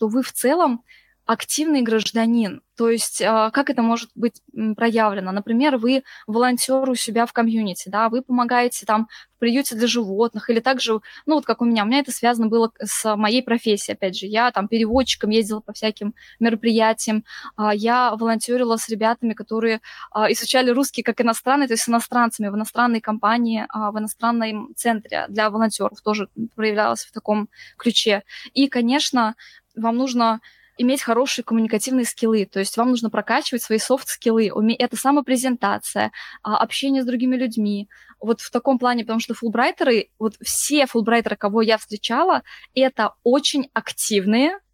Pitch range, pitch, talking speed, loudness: 220-250 Hz, 230 Hz, 155 wpm, -20 LUFS